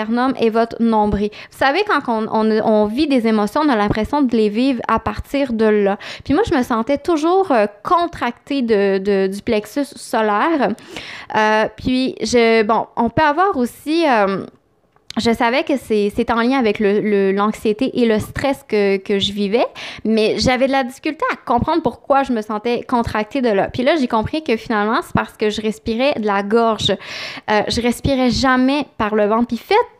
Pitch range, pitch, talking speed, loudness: 215-270 Hz, 230 Hz, 200 wpm, -17 LUFS